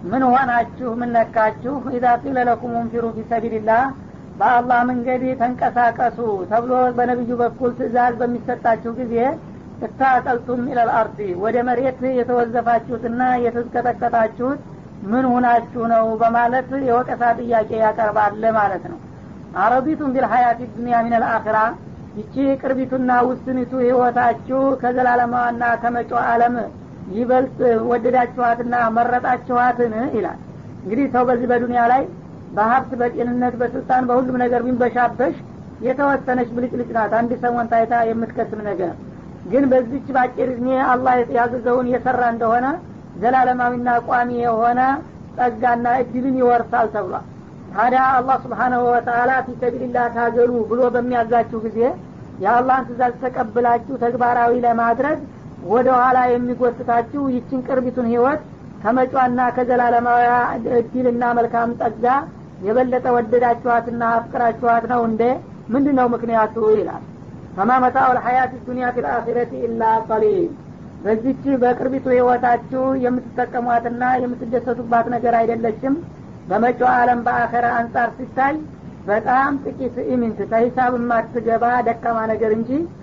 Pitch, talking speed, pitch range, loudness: 245 Hz, 105 wpm, 235-250 Hz, -18 LUFS